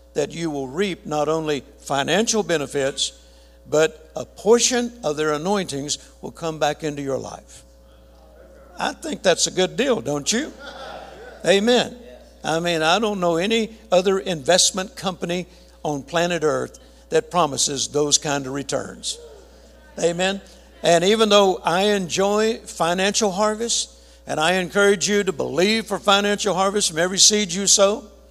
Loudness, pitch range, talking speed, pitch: -20 LUFS, 150-205 Hz, 145 wpm, 175 Hz